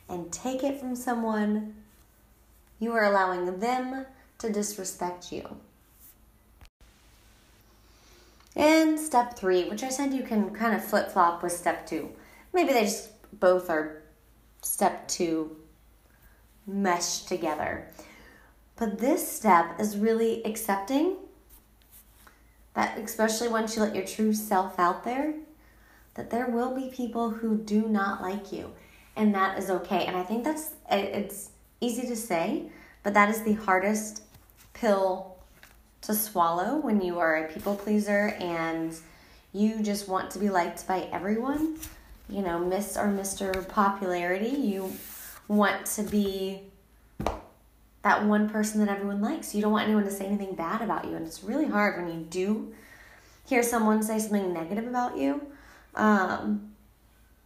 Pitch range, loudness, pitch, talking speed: 185-230 Hz, -28 LUFS, 210 Hz, 145 wpm